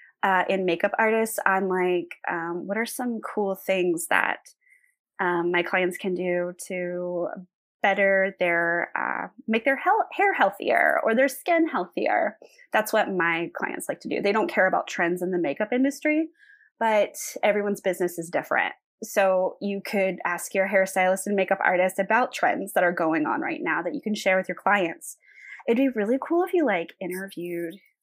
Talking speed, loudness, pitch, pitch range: 180 wpm, -25 LUFS, 195 Hz, 180-260 Hz